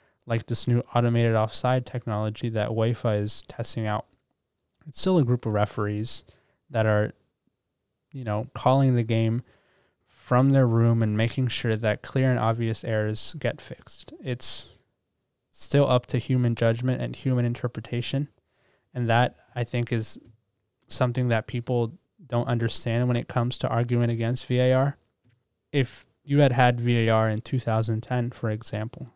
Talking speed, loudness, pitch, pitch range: 150 wpm, -25 LUFS, 120 Hz, 110-125 Hz